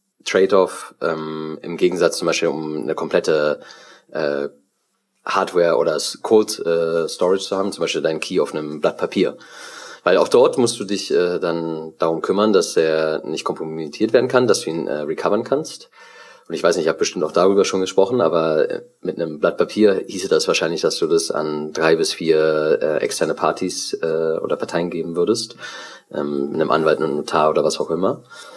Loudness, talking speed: -19 LUFS, 190 wpm